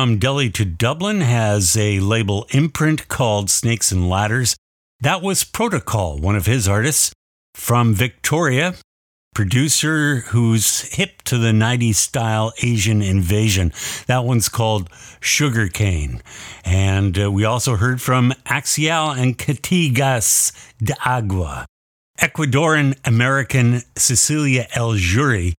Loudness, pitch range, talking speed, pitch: -17 LUFS, 100-135 Hz, 115 wpm, 115 Hz